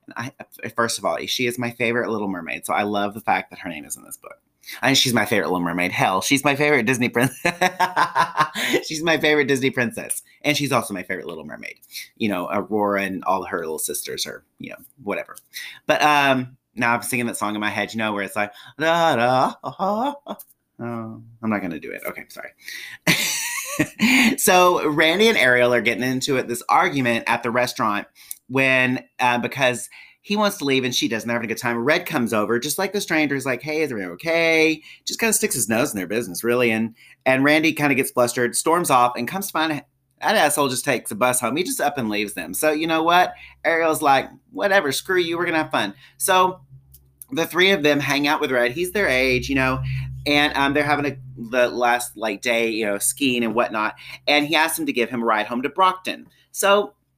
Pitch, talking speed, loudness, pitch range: 130 Hz, 230 wpm, -20 LUFS, 120-160 Hz